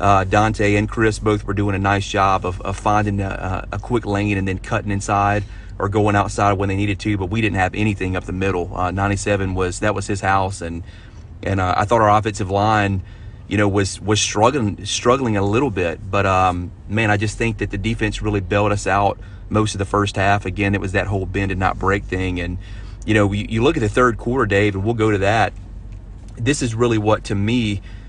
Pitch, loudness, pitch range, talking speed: 100 Hz, -19 LUFS, 95-105 Hz, 235 wpm